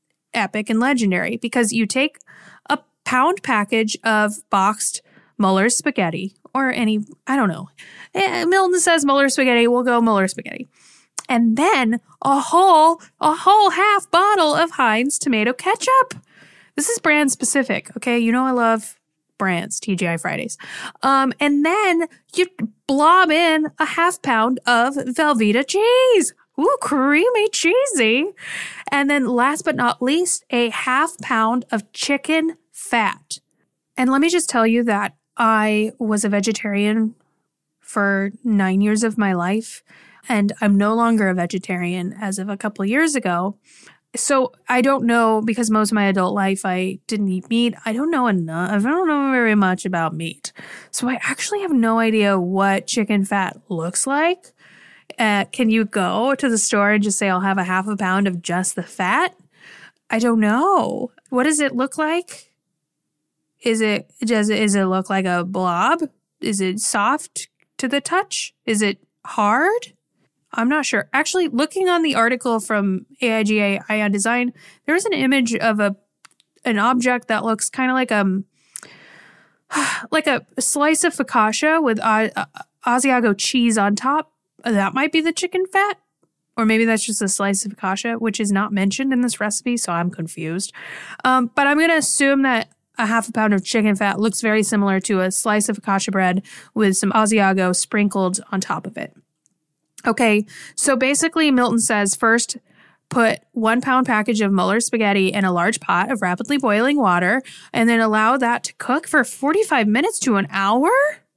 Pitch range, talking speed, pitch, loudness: 205-275 Hz, 170 wpm, 230 Hz, -18 LUFS